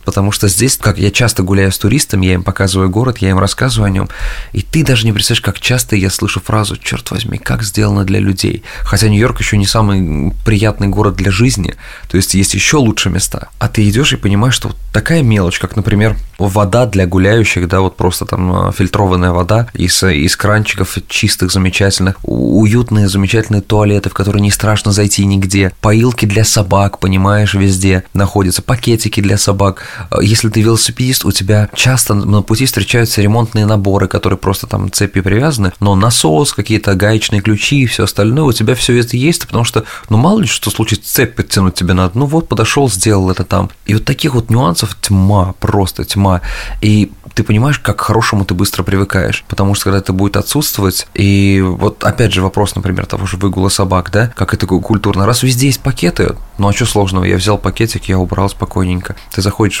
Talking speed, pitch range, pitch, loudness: 190 wpm, 95-110 Hz, 100 Hz, -12 LUFS